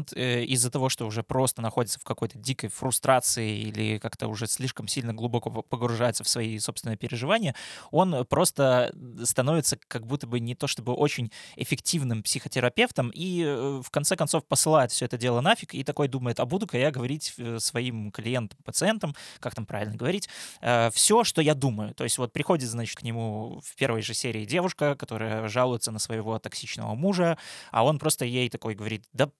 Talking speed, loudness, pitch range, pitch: 175 wpm, -27 LUFS, 115-145 Hz, 125 Hz